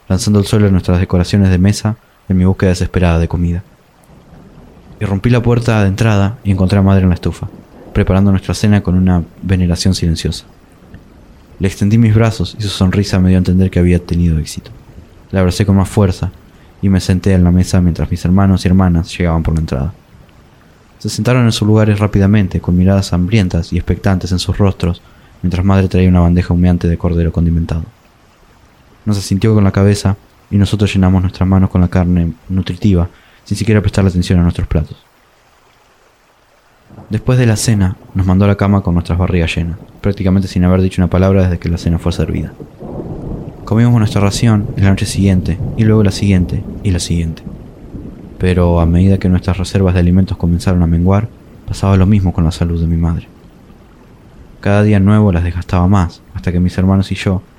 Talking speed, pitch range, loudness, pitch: 190 wpm, 90-100 Hz, -13 LUFS, 95 Hz